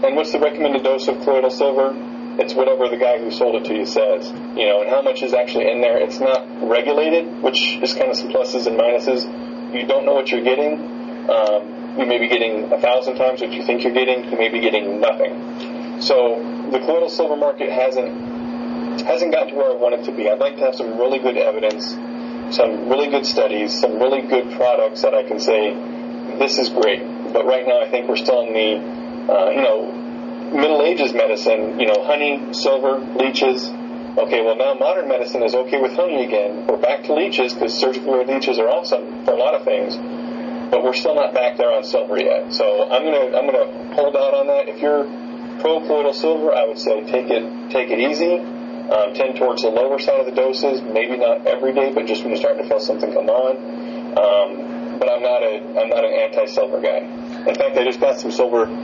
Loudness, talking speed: -18 LUFS, 220 wpm